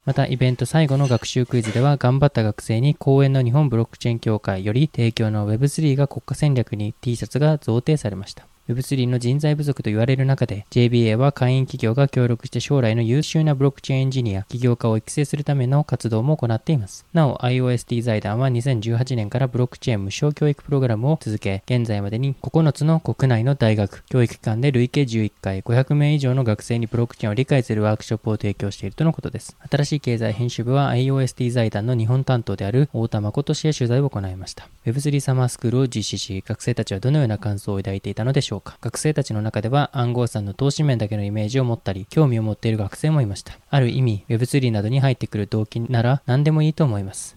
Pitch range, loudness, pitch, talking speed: 110-140 Hz, -21 LUFS, 125 Hz, 465 characters per minute